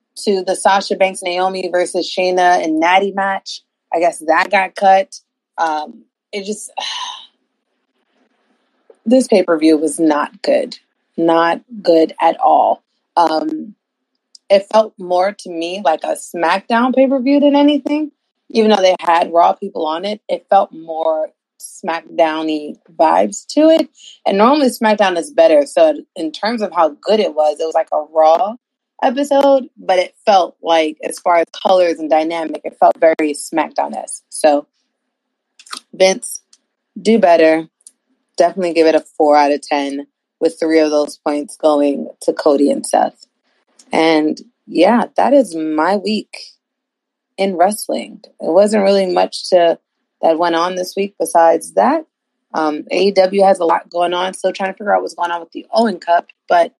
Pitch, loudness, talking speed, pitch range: 185 Hz, -15 LUFS, 165 wpm, 165-230 Hz